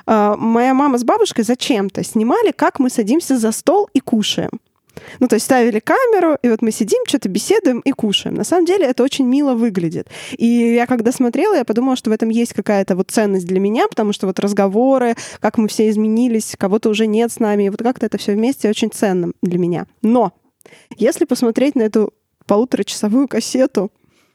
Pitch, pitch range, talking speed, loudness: 230 Hz, 215-260 Hz, 190 wpm, -16 LUFS